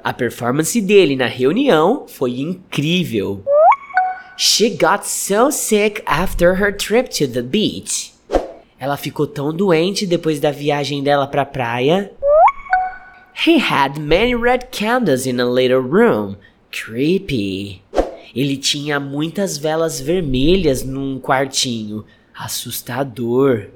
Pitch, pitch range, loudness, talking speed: 150 Hz, 130-210 Hz, -17 LUFS, 115 wpm